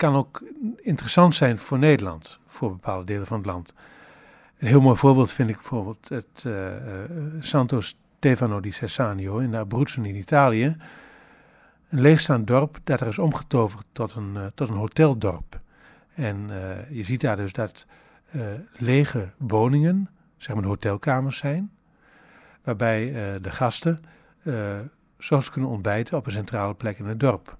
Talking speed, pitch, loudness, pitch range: 165 wpm, 125 Hz, -24 LUFS, 105-145 Hz